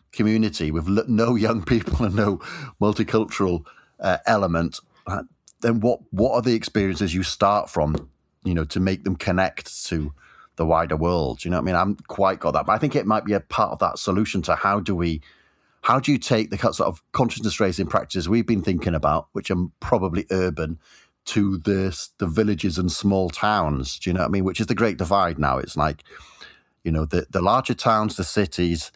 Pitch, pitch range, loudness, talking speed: 95 Hz, 85-110 Hz, -23 LUFS, 210 wpm